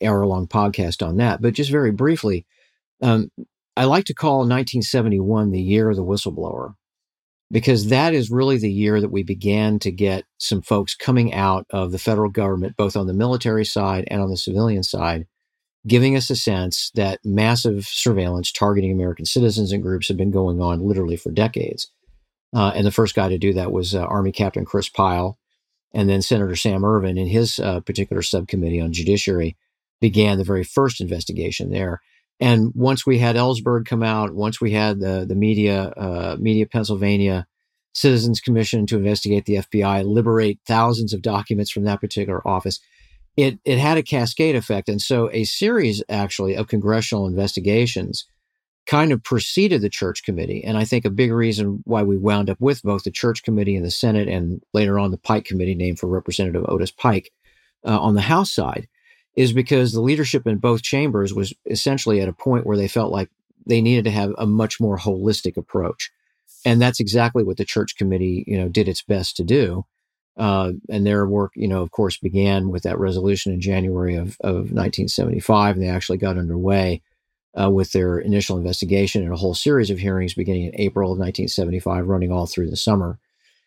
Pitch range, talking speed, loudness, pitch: 95-115 Hz, 190 wpm, -20 LUFS, 105 Hz